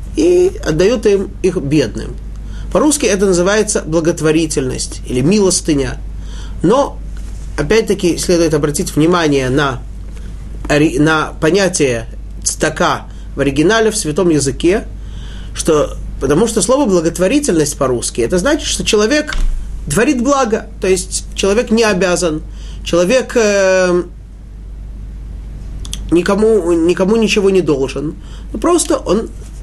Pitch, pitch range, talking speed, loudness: 175 Hz, 145-215 Hz, 110 wpm, -14 LUFS